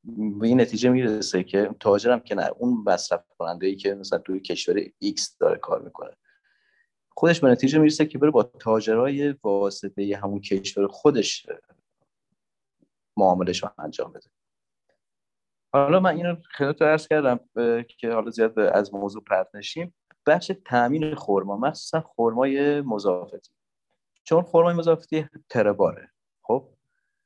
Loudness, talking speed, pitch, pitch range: -23 LUFS, 135 wpm, 140 Hz, 110-170 Hz